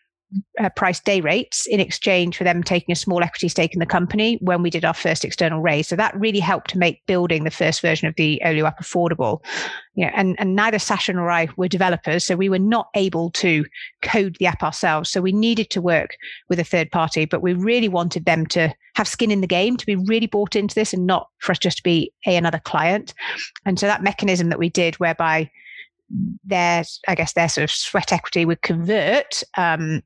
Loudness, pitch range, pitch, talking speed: -20 LUFS, 170-200 Hz, 180 Hz, 230 wpm